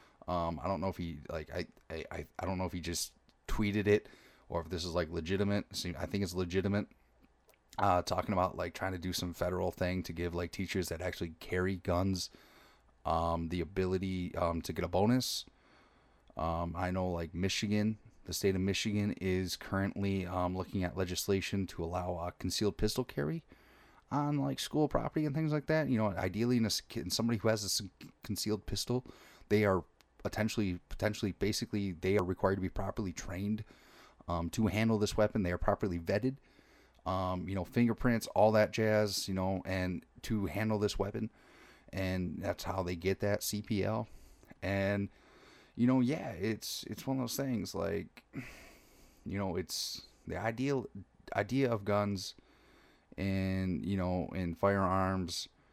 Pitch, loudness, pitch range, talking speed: 95 Hz, -35 LUFS, 90-105 Hz, 175 wpm